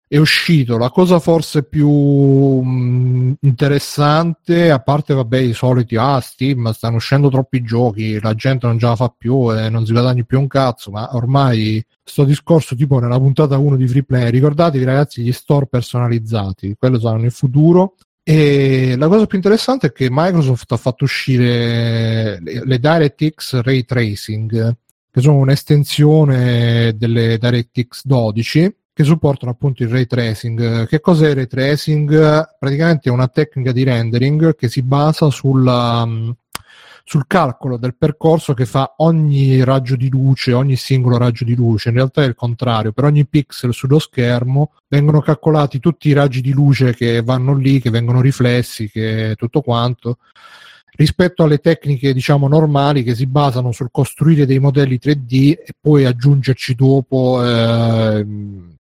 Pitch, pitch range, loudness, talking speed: 130 Hz, 120-145 Hz, -14 LUFS, 160 wpm